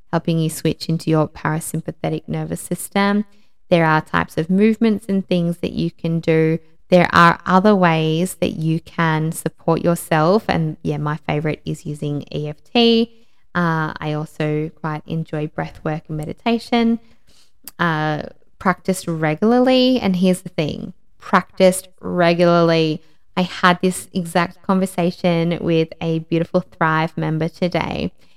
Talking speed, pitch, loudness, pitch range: 135 wpm, 170 Hz, -19 LUFS, 155-185 Hz